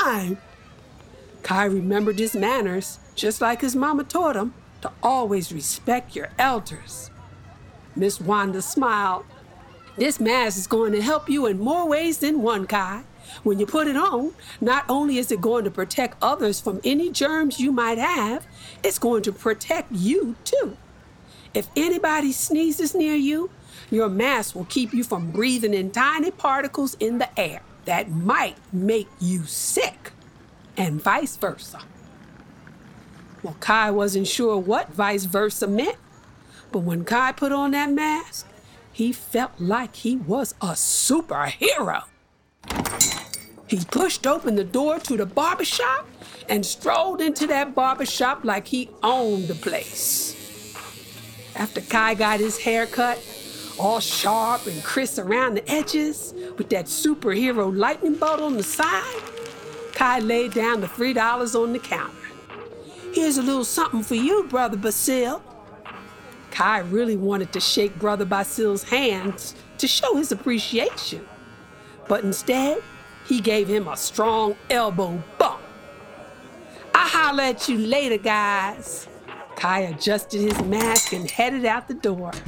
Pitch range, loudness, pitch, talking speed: 205-275 Hz, -22 LUFS, 230 Hz, 145 wpm